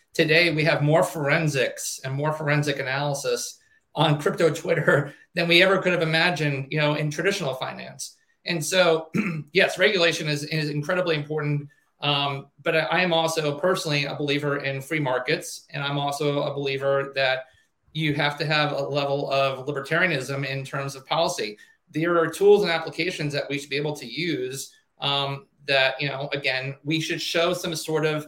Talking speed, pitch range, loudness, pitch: 175 wpm, 140-165 Hz, -23 LUFS, 150 Hz